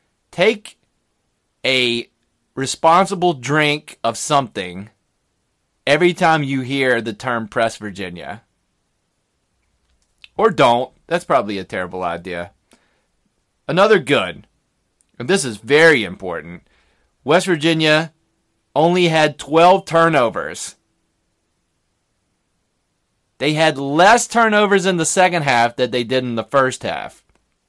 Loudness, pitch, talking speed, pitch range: -16 LUFS, 130 Hz, 105 wpm, 105-160 Hz